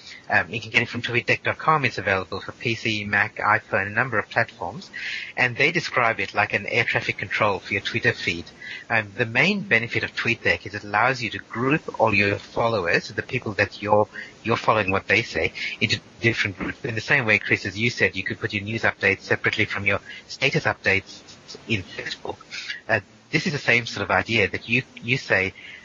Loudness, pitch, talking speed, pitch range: -22 LUFS, 110 Hz, 210 wpm, 105-120 Hz